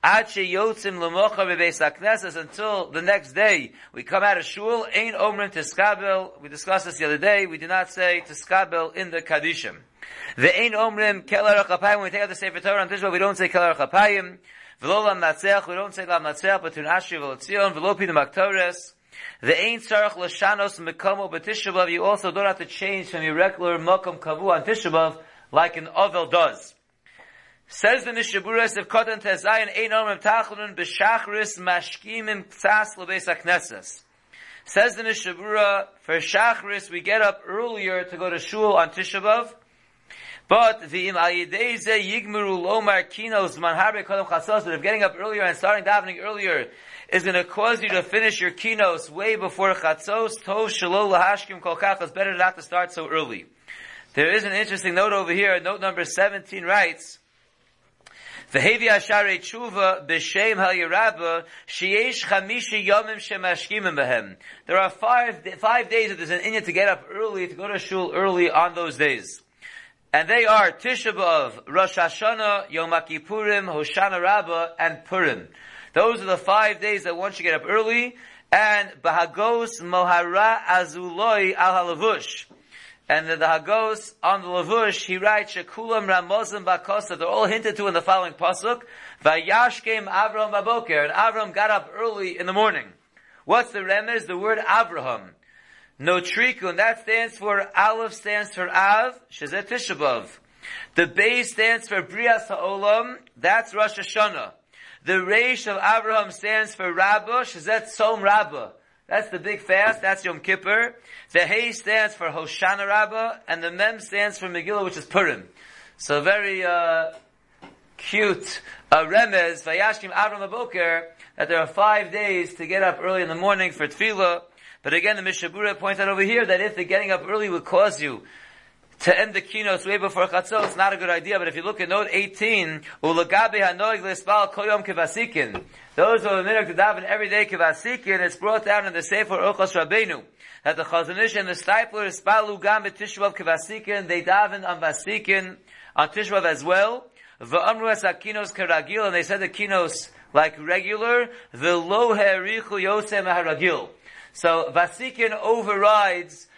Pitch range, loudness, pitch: 180-215 Hz, -22 LUFS, 195 Hz